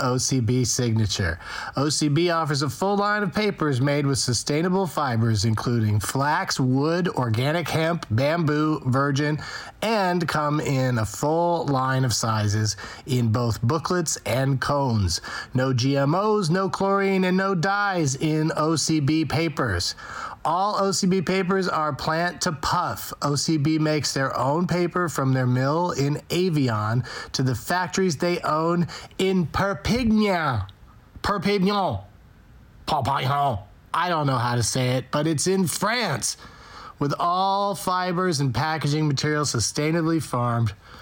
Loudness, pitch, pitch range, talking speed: -23 LUFS, 150 Hz, 130-175 Hz, 130 wpm